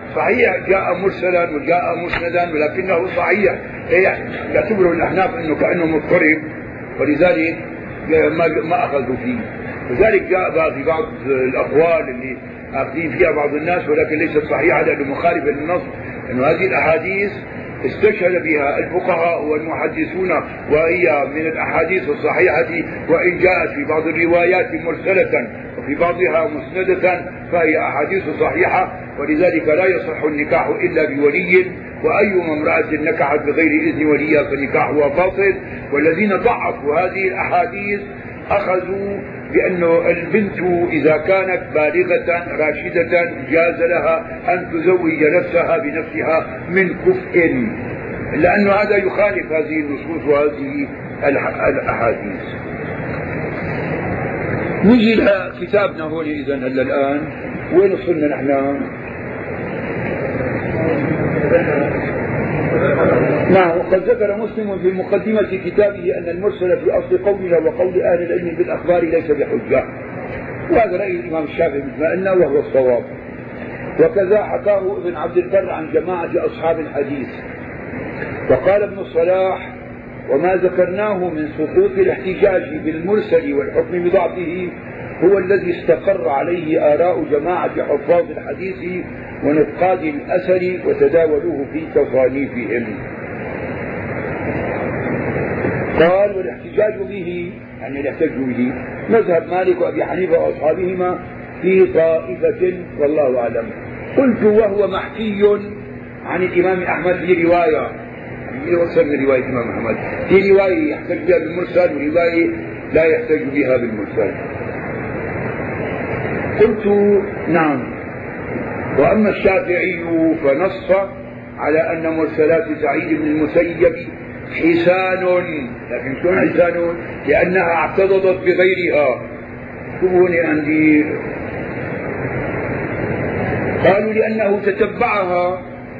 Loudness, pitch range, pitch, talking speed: -17 LUFS, 155-195 Hz, 175 Hz, 100 wpm